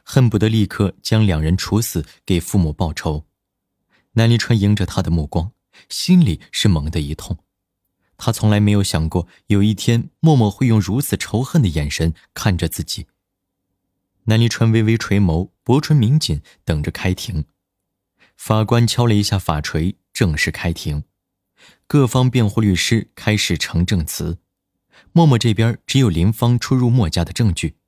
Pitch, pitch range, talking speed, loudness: 100 Hz, 85-115 Hz, 235 characters per minute, -18 LUFS